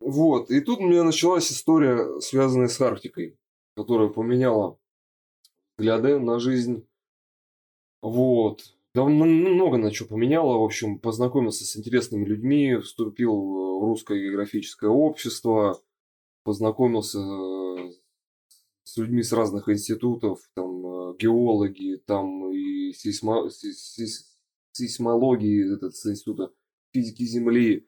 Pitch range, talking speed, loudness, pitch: 100-125 Hz, 110 wpm, -24 LUFS, 115 Hz